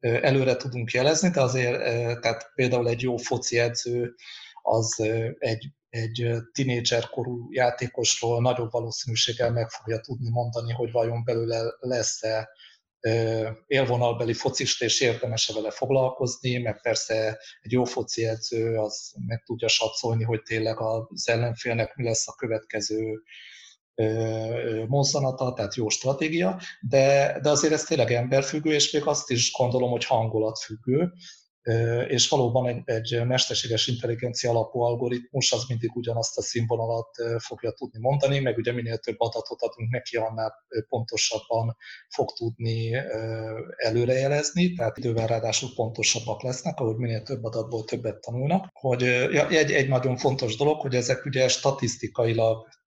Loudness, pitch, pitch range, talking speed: -26 LUFS, 120 Hz, 115-130 Hz, 130 wpm